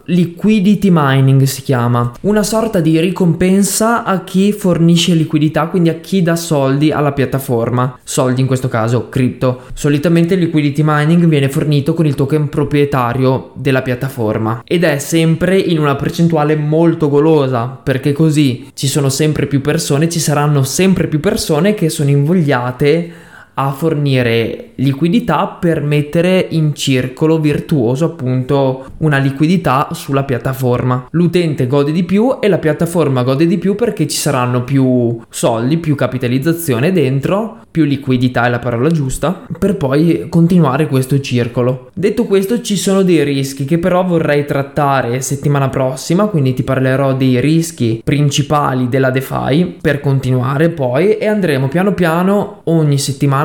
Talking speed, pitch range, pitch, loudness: 145 wpm, 135-170 Hz, 150 Hz, -13 LUFS